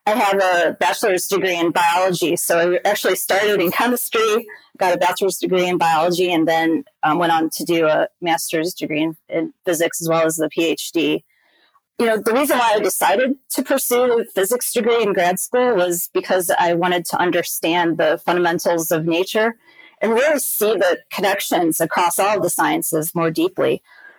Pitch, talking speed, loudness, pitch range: 185 Hz, 180 wpm, -18 LUFS, 170-235 Hz